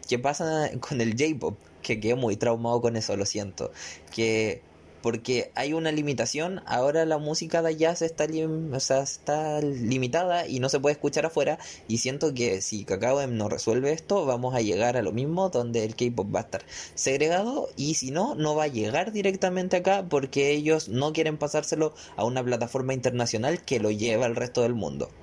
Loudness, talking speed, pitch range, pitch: -27 LUFS, 195 wpm, 115-155 Hz, 135 Hz